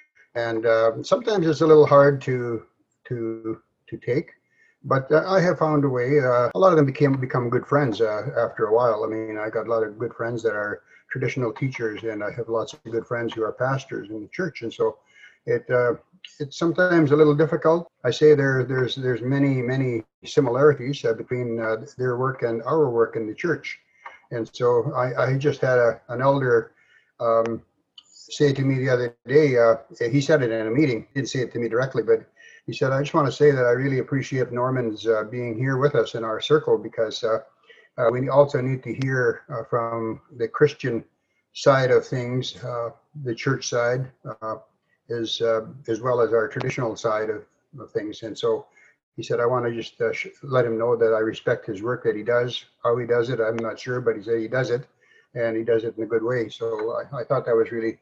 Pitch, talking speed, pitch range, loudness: 125 Hz, 220 wpm, 115-150 Hz, -23 LUFS